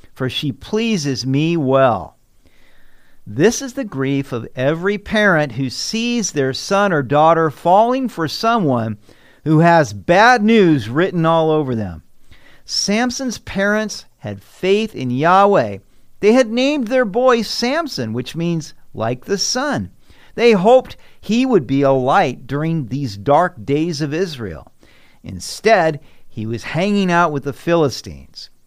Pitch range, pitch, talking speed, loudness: 130-210 Hz, 160 Hz, 140 wpm, -16 LUFS